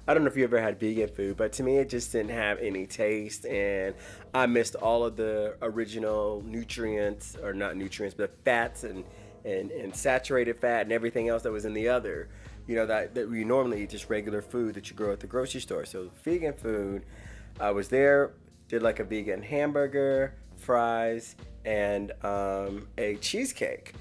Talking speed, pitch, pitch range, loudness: 190 wpm, 110 Hz, 100-120 Hz, -30 LUFS